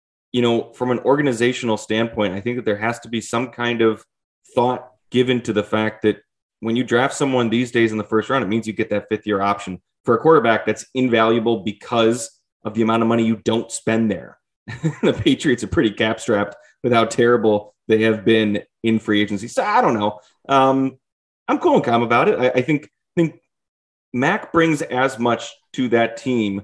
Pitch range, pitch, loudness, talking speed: 110-125 Hz, 115 Hz, -19 LUFS, 205 wpm